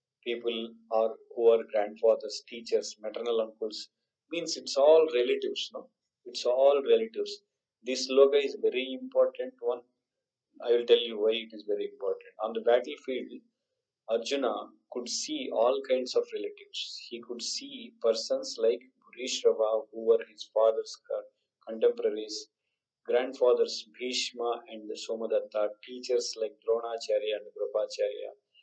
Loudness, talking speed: -30 LUFS, 130 wpm